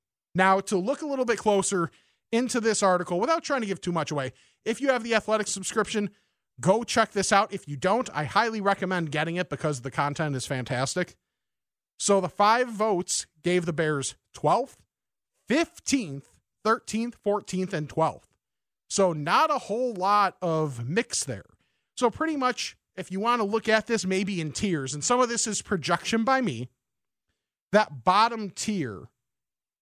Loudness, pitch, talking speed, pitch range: -26 LUFS, 195 Hz, 170 wpm, 160-225 Hz